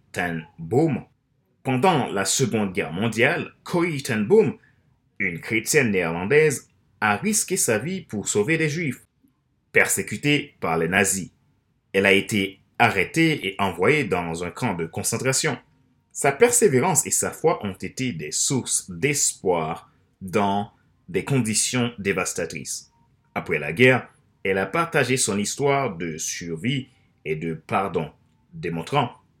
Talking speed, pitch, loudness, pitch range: 130 wpm, 125 Hz, -22 LUFS, 100-155 Hz